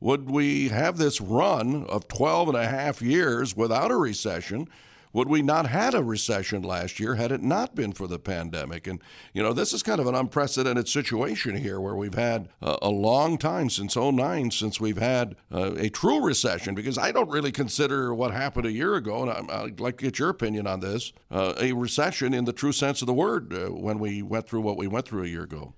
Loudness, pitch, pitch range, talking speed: -26 LUFS, 120 Hz, 100-135 Hz, 225 wpm